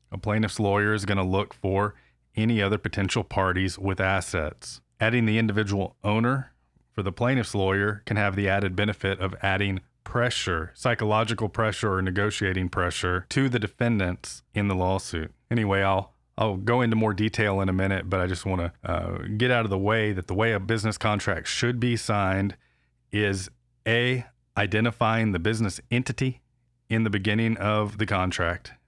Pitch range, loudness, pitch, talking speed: 95-110 Hz, -26 LUFS, 105 Hz, 170 wpm